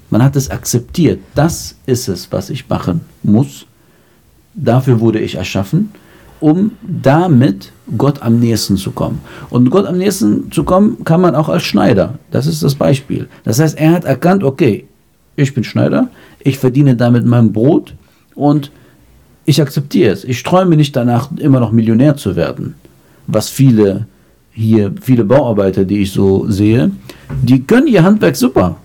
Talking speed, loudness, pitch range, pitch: 160 wpm, -12 LUFS, 110-150 Hz, 125 Hz